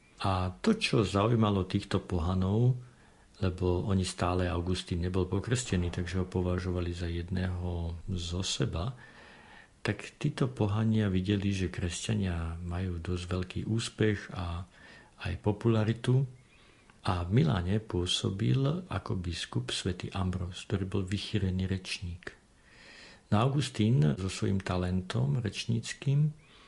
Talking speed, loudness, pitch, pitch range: 110 wpm, -32 LUFS, 95 Hz, 90-115 Hz